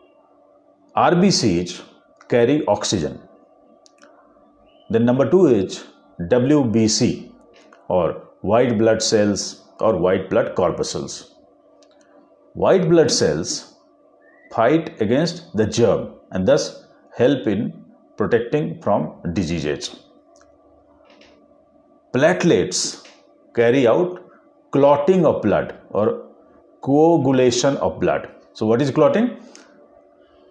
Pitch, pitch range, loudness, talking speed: 125 Hz, 105-150 Hz, -19 LUFS, 85 wpm